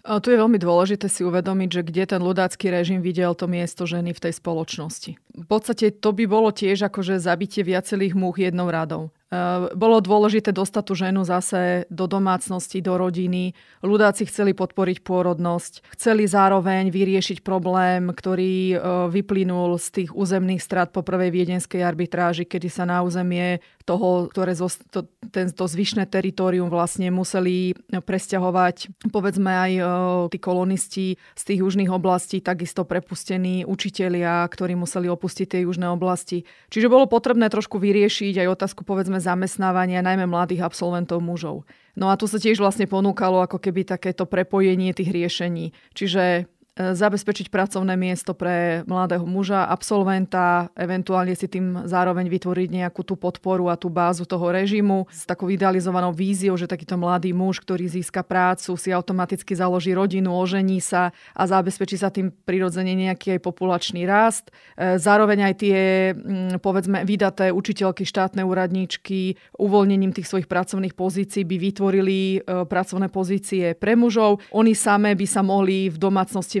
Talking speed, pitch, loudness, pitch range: 150 wpm, 185 Hz, -22 LUFS, 180-195 Hz